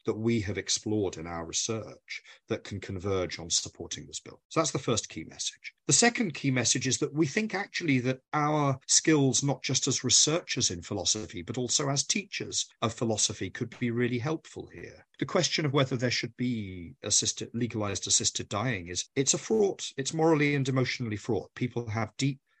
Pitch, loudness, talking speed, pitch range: 125 Hz, -28 LUFS, 190 wpm, 110-140 Hz